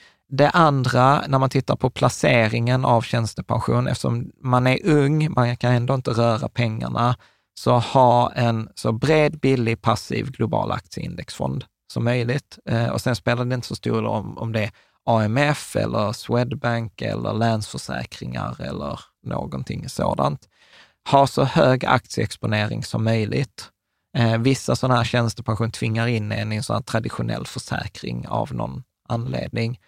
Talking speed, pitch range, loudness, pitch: 150 wpm, 110-130 Hz, -22 LUFS, 120 Hz